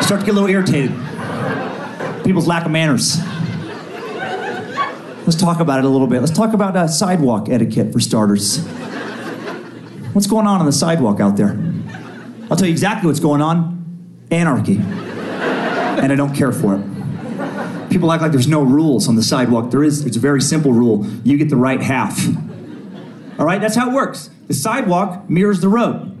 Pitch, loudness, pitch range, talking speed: 165 Hz, -16 LUFS, 135-185 Hz, 180 wpm